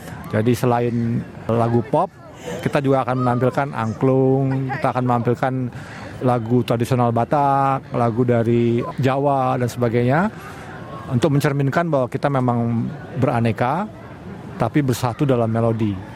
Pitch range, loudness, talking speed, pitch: 120-135 Hz, -20 LUFS, 110 wpm, 125 Hz